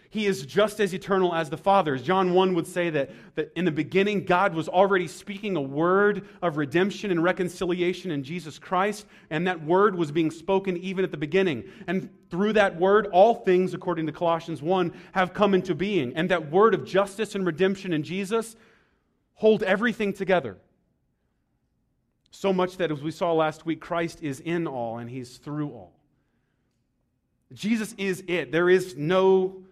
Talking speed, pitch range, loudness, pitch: 180 wpm, 165-195 Hz, -25 LUFS, 185 Hz